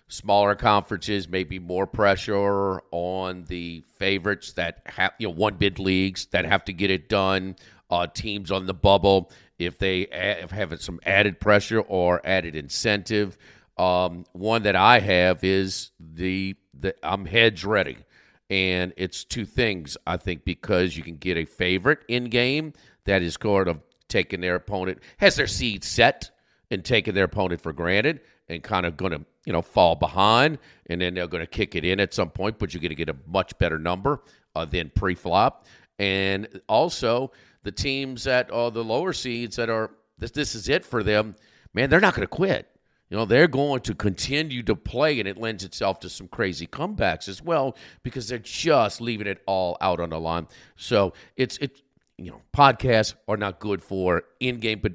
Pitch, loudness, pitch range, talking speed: 100 Hz, -24 LUFS, 90-110 Hz, 190 wpm